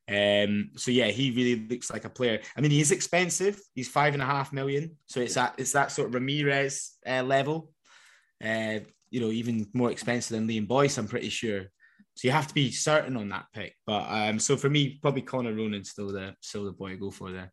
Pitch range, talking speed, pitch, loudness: 110-140 Hz, 235 wpm, 125 Hz, -28 LUFS